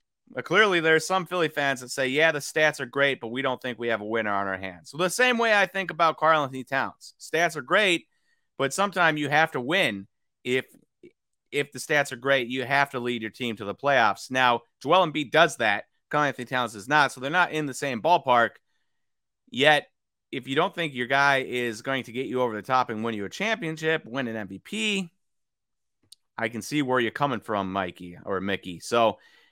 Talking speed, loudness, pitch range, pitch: 220 wpm, -25 LUFS, 115-160 Hz, 135 Hz